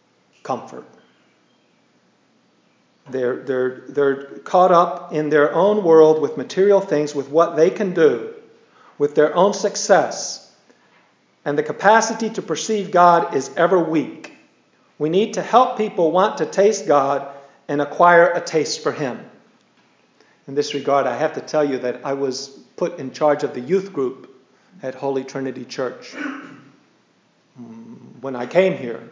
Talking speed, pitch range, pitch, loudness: 150 wpm, 140-195 Hz, 160 Hz, -18 LUFS